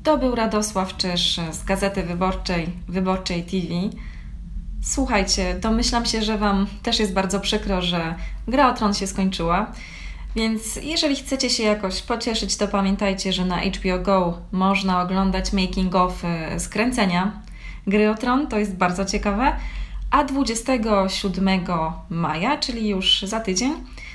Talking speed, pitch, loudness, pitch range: 135 wpm, 195 Hz, -22 LUFS, 185-220 Hz